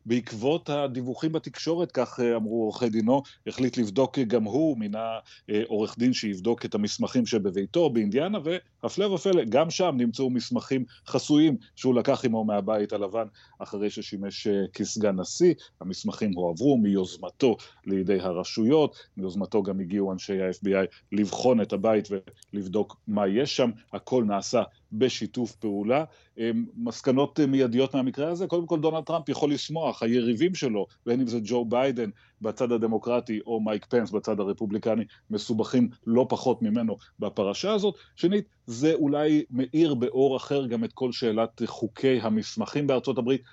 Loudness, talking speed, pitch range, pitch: -27 LUFS, 140 wpm, 110-145 Hz, 120 Hz